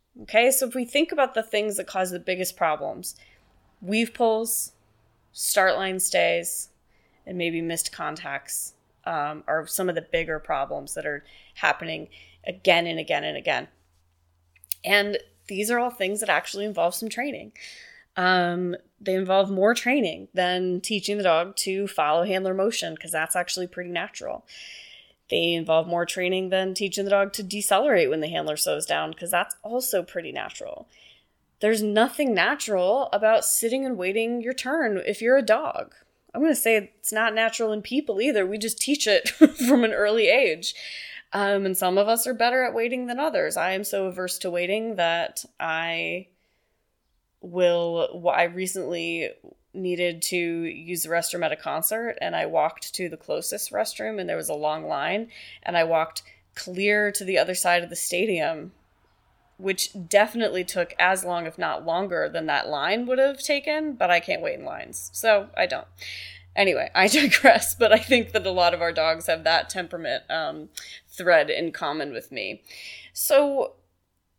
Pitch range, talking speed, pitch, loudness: 170-225 Hz, 175 wpm, 190 Hz, -24 LUFS